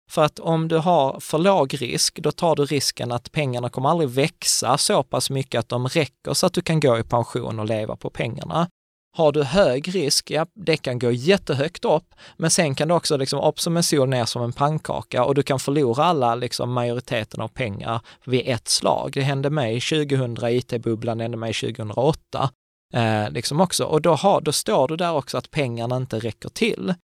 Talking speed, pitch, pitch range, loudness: 205 wpm, 140 Hz, 120-160 Hz, -22 LUFS